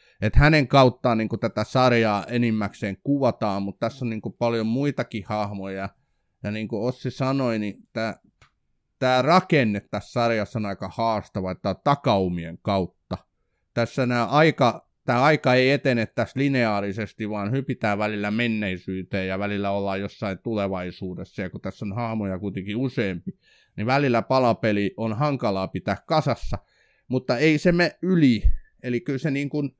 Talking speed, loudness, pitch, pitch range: 155 wpm, -24 LUFS, 115 Hz, 100-130 Hz